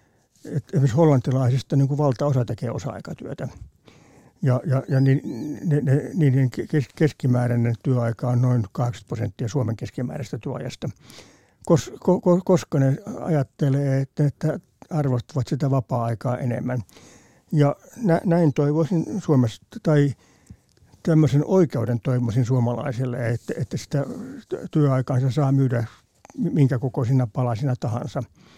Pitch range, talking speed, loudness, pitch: 125-150 Hz, 110 wpm, -23 LUFS, 135 Hz